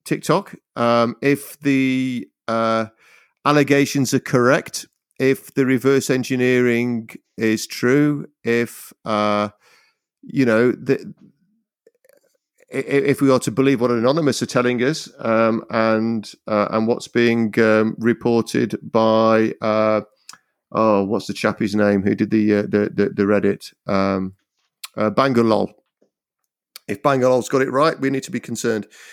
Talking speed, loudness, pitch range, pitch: 135 wpm, -19 LUFS, 110-135 Hz, 120 Hz